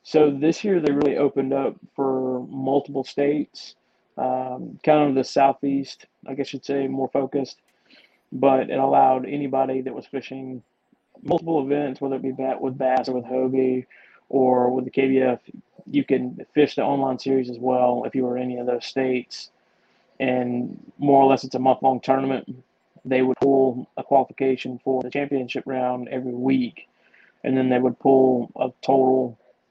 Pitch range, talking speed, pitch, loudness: 130-135 Hz, 170 wpm, 130 Hz, -22 LUFS